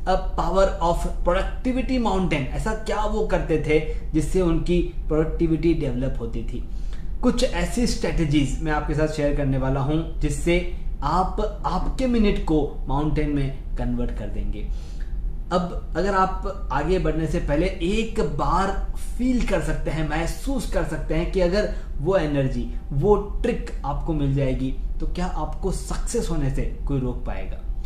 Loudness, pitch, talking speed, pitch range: -25 LUFS, 160 Hz, 150 wpm, 140-190 Hz